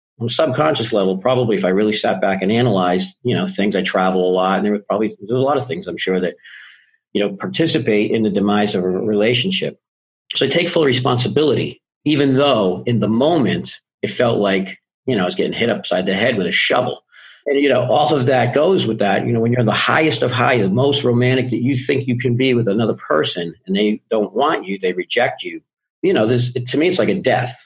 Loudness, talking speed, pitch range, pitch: -17 LUFS, 245 wpm, 100-135 Hz, 115 Hz